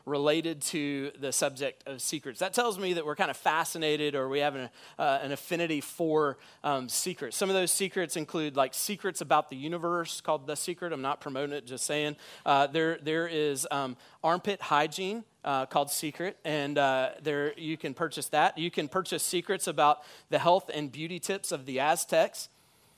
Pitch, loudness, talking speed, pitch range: 155 Hz, -30 LUFS, 190 wpm, 145-175 Hz